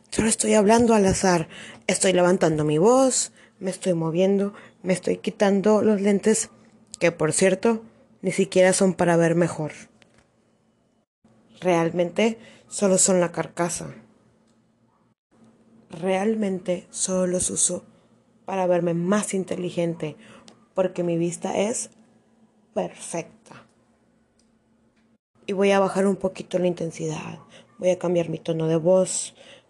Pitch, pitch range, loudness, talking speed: 185 Hz, 175-205 Hz, -22 LUFS, 120 wpm